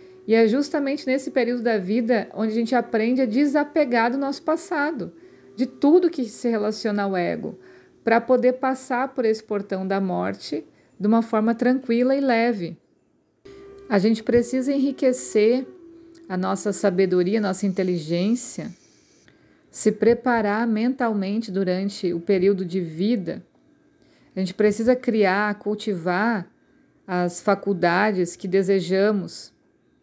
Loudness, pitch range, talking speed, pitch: -22 LUFS, 195-255 Hz, 130 wpm, 225 Hz